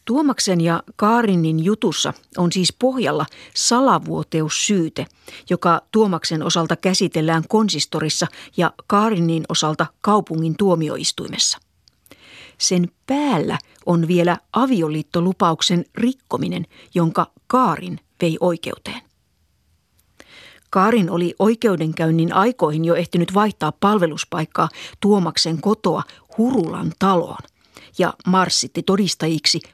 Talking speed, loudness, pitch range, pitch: 85 wpm, -19 LUFS, 160-205 Hz, 175 Hz